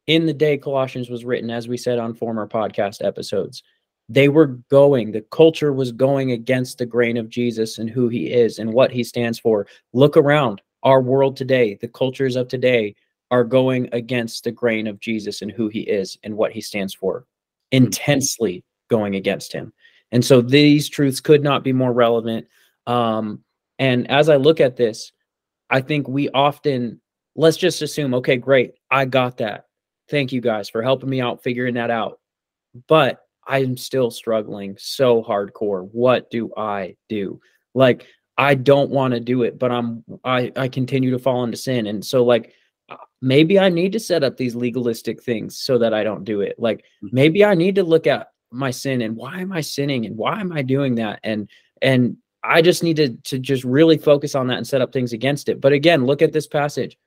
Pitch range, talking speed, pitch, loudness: 115-140 Hz, 200 wpm, 125 Hz, -19 LUFS